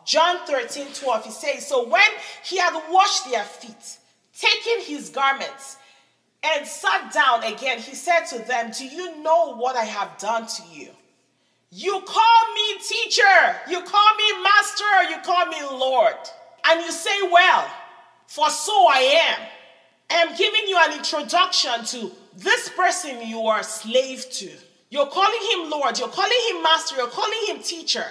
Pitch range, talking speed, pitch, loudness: 255-390 Hz, 165 wpm, 325 Hz, -20 LUFS